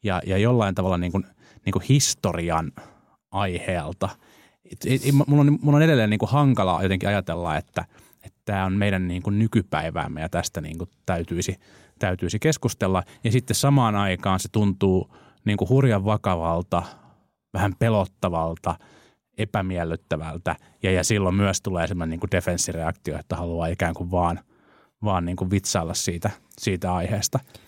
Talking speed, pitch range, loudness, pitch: 150 wpm, 90-105 Hz, -24 LUFS, 95 Hz